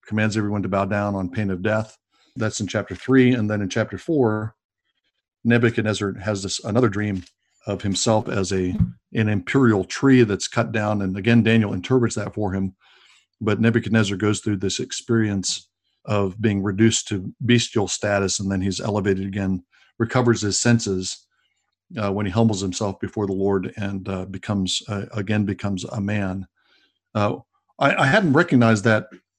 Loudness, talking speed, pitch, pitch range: -22 LUFS, 165 wpm, 105 Hz, 95-110 Hz